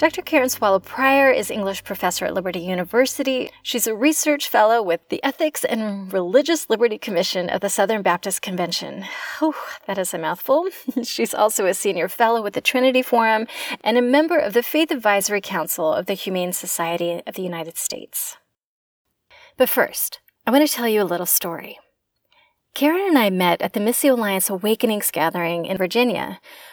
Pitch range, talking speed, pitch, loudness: 185-270 Hz, 175 wpm, 220 Hz, -20 LUFS